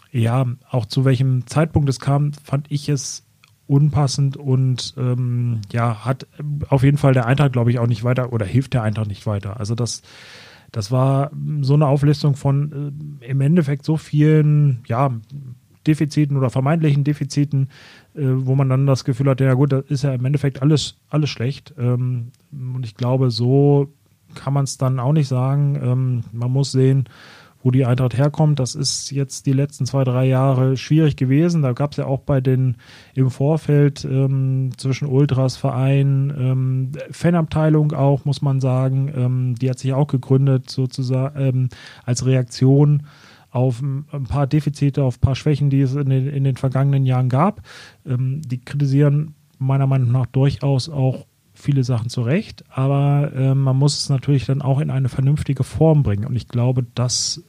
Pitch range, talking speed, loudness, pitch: 130-145 Hz, 180 wpm, -19 LUFS, 135 Hz